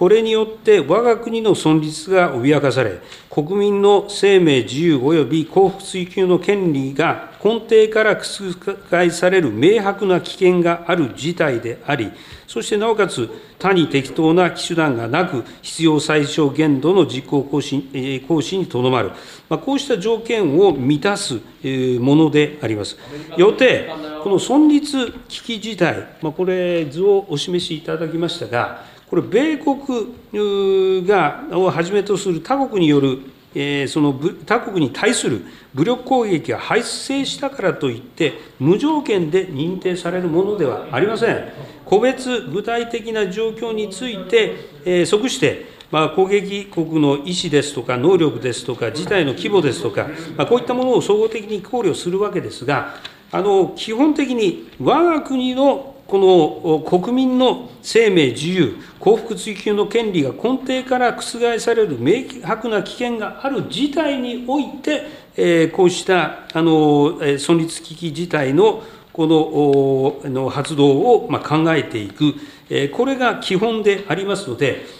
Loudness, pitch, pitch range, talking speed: -18 LUFS, 185 Hz, 155-230 Hz, 275 characters per minute